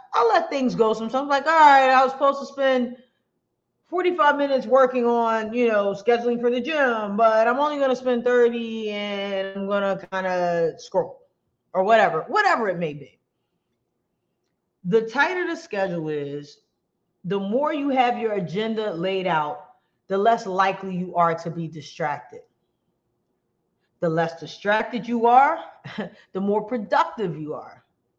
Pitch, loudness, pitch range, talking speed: 220 Hz, -22 LUFS, 190-255 Hz, 160 wpm